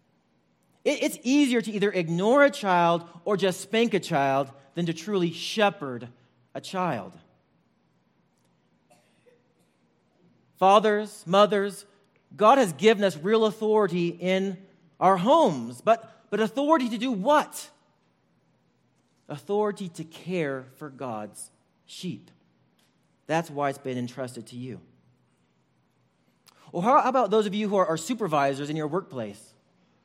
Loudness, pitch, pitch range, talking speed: -25 LUFS, 185 Hz, 140-210 Hz, 125 wpm